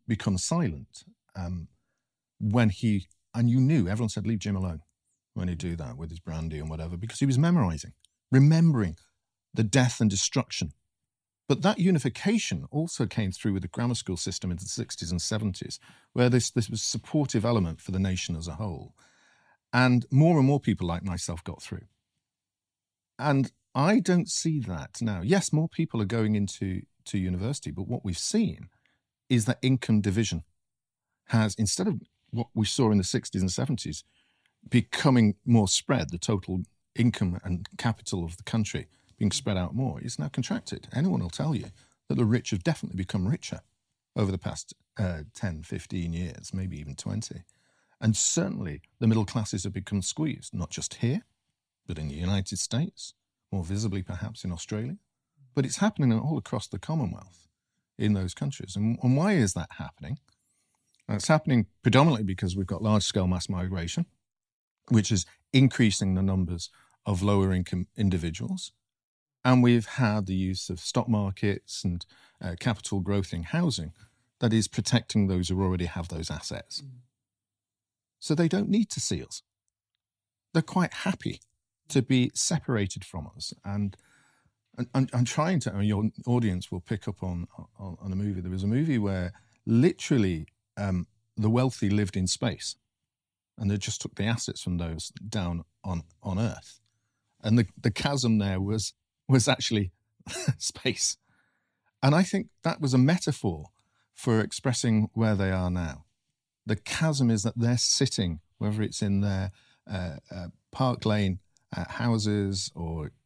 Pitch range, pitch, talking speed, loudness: 95-125 Hz, 105 Hz, 165 wpm, -28 LUFS